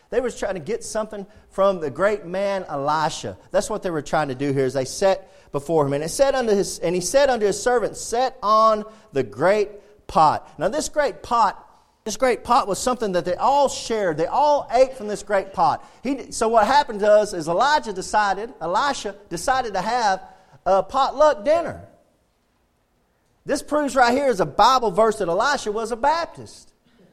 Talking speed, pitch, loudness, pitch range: 190 wpm, 210 Hz, -21 LUFS, 185-260 Hz